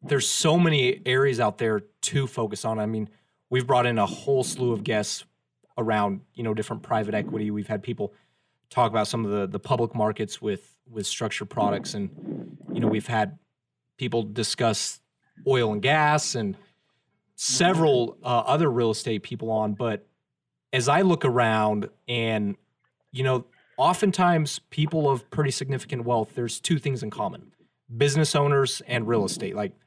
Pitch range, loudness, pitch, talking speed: 110-135 Hz, -25 LUFS, 120 Hz, 165 wpm